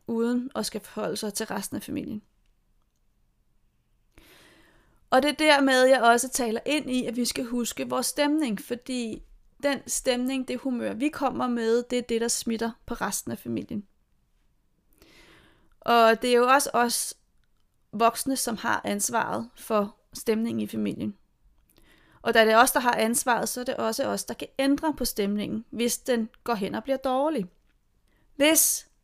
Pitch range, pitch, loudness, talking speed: 225-260 Hz, 240 Hz, -25 LUFS, 165 wpm